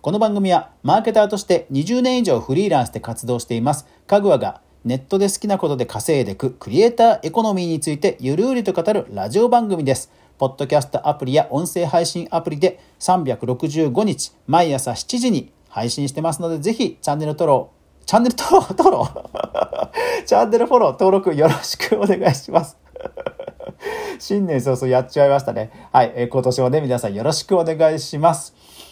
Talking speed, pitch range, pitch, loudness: 380 characters per minute, 140-215 Hz, 170 Hz, -18 LUFS